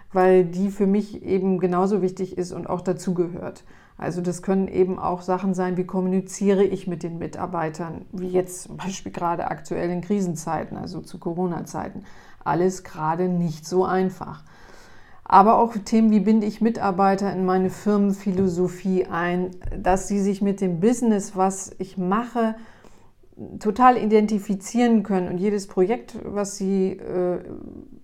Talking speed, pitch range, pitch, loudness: 150 wpm, 180-200 Hz, 190 Hz, -23 LUFS